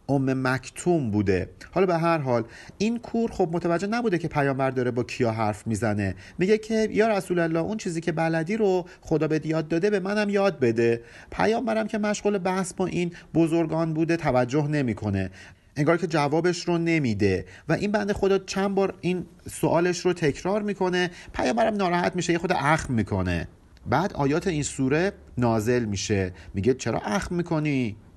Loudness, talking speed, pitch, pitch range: -25 LUFS, 170 wpm, 165 Hz, 120-185 Hz